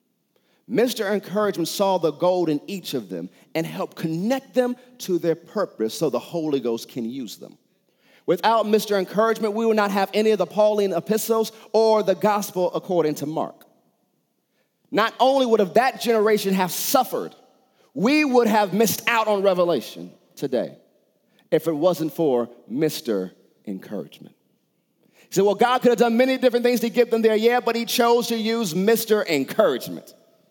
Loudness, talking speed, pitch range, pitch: -21 LUFS, 165 wpm, 170-230 Hz, 210 Hz